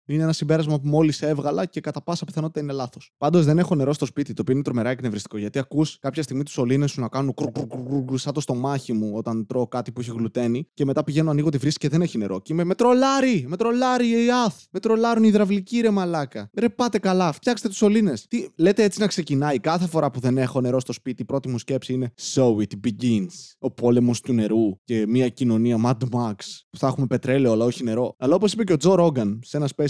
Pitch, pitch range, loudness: 140 Hz, 125-170 Hz, -22 LUFS